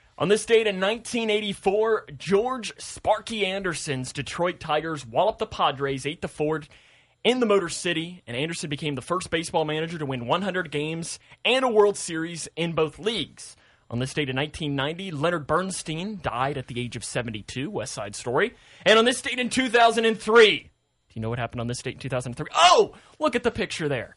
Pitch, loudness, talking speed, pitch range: 165 Hz, -25 LUFS, 190 wpm, 140-210 Hz